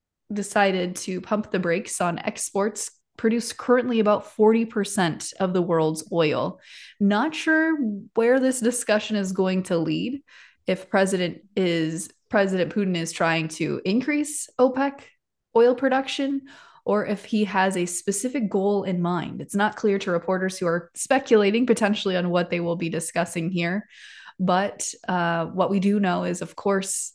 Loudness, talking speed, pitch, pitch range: -24 LUFS, 155 wpm, 200 Hz, 175-225 Hz